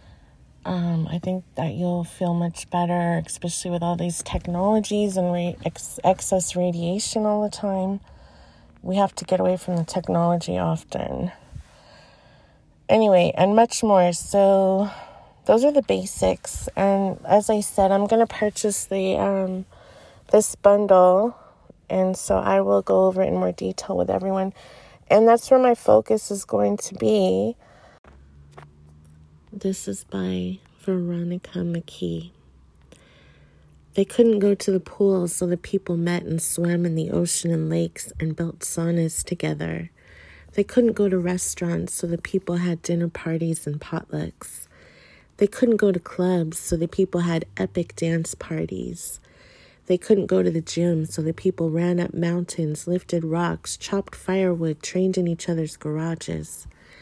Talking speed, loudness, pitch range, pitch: 150 wpm, -22 LUFS, 155-190 Hz, 175 Hz